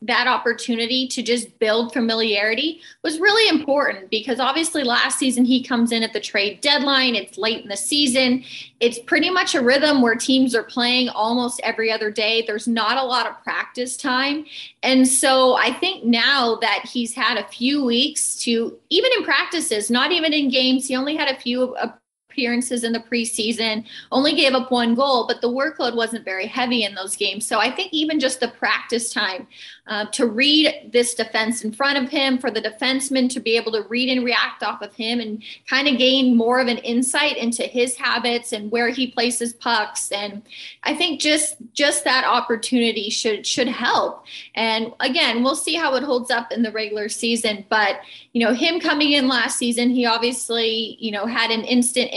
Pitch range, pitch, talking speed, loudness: 230-265 Hz, 245 Hz, 195 wpm, -19 LUFS